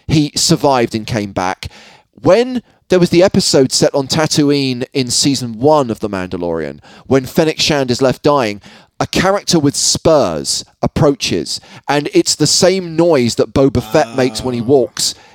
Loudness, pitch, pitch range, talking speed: -13 LUFS, 140 Hz, 120-155 Hz, 165 wpm